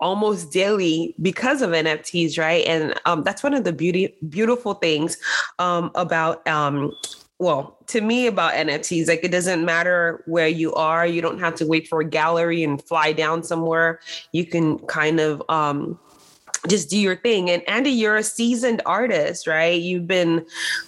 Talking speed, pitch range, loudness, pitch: 170 wpm, 160-190 Hz, -21 LUFS, 170 Hz